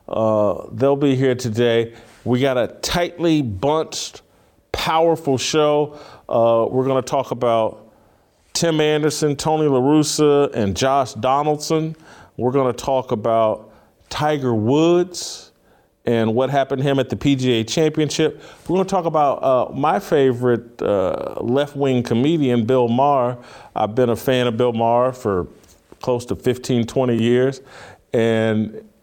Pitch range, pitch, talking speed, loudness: 120-150 Hz, 130 Hz, 140 wpm, -19 LUFS